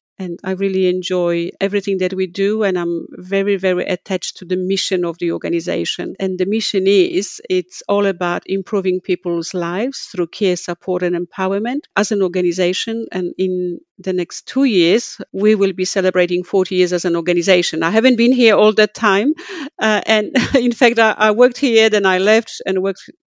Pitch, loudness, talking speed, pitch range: 190 Hz, -16 LUFS, 185 wpm, 180-215 Hz